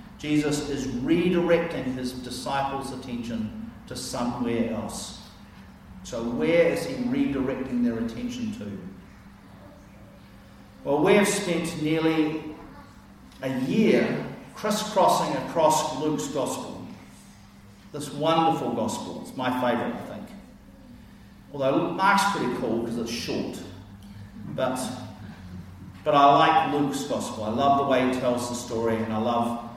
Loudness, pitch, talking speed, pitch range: -25 LUFS, 140 Hz, 120 wpm, 115-165 Hz